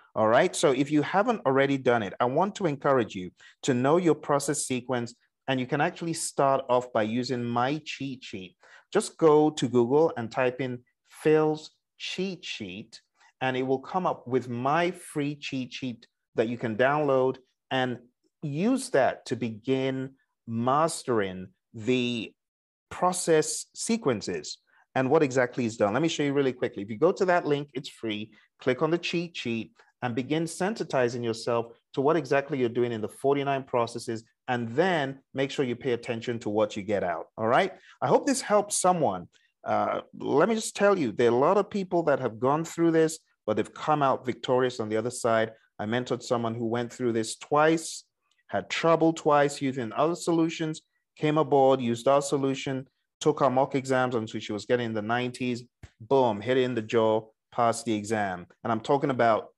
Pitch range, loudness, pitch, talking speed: 120-155 Hz, -27 LUFS, 130 Hz, 190 wpm